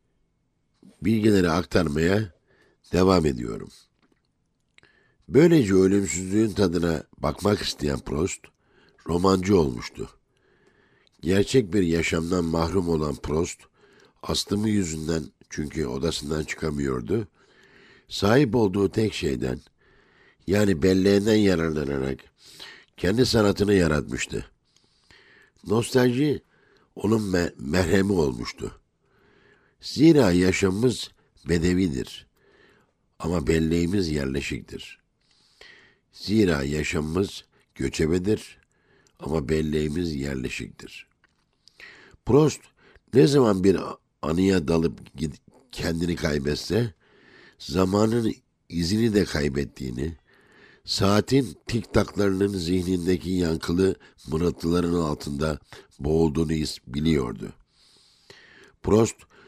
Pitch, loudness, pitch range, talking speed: 90 Hz, -24 LUFS, 80-100 Hz, 70 wpm